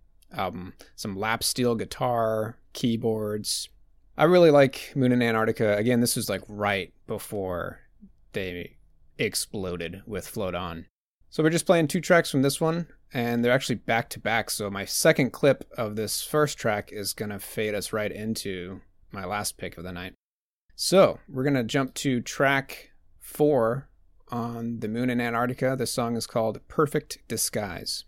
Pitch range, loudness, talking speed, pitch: 100-135 Hz, -26 LUFS, 165 wpm, 115 Hz